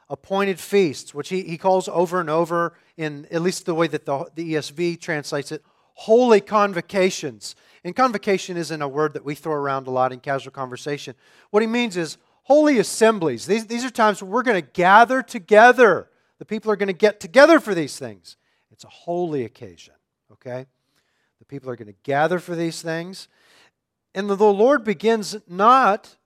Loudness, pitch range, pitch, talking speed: -20 LUFS, 145-210 Hz, 175 Hz, 185 wpm